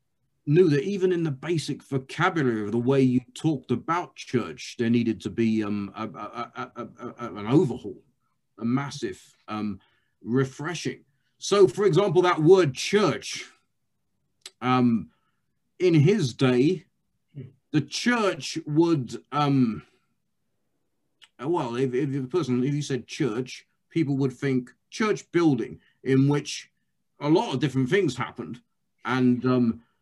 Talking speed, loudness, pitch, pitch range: 135 wpm, -25 LUFS, 135 Hz, 125-160 Hz